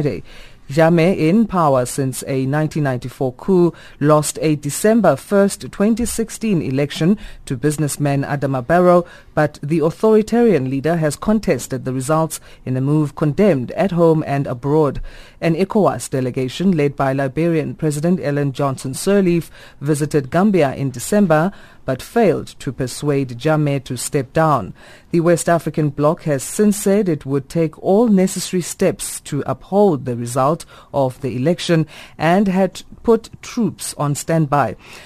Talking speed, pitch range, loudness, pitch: 140 wpm, 135-175 Hz, -18 LUFS, 155 Hz